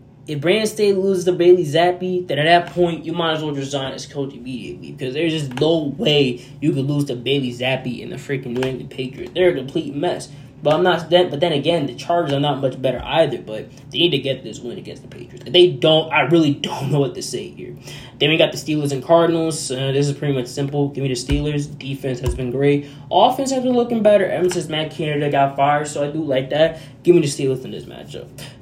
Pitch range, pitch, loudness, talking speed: 135-170 Hz, 145 Hz, -19 LUFS, 245 wpm